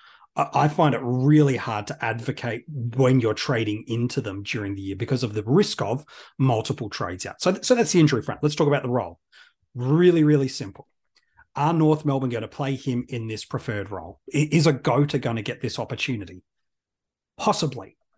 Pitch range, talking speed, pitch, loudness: 115-145 Hz, 190 wpm, 130 Hz, -23 LUFS